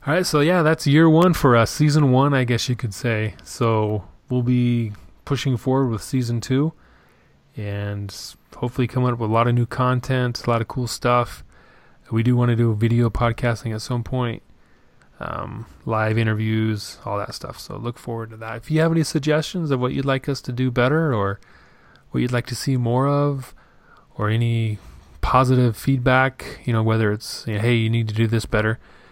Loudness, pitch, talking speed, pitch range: -21 LUFS, 120 Hz, 200 wpm, 110-130 Hz